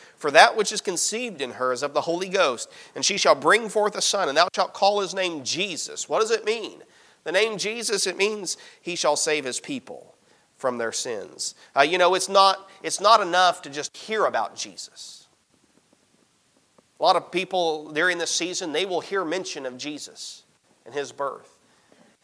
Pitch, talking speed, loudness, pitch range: 190 Hz, 195 wpm, -23 LUFS, 165-215 Hz